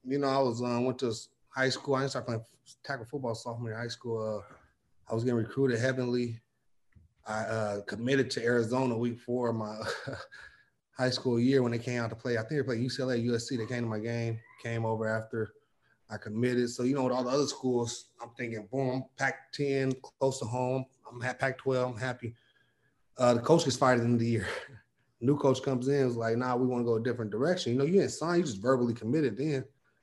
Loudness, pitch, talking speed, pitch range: -31 LUFS, 125 Hz, 230 wpm, 115-130 Hz